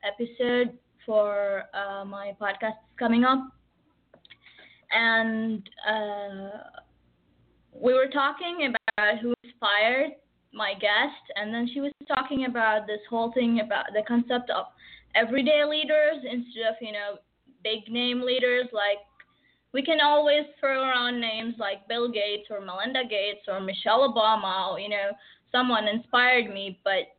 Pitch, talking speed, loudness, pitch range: 225 Hz, 135 wpm, -26 LUFS, 205-255 Hz